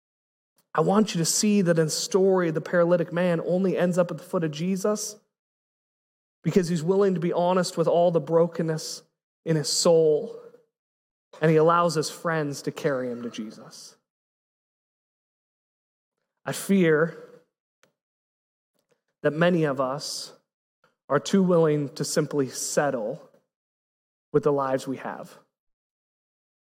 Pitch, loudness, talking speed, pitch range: 170 Hz, -24 LUFS, 135 wpm, 155-190 Hz